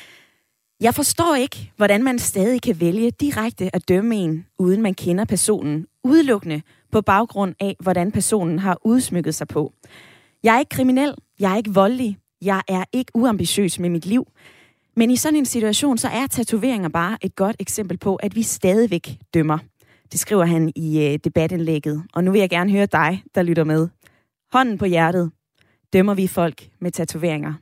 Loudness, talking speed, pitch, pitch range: -20 LUFS, 175 wpm, 190 Hz, 165-225 Hz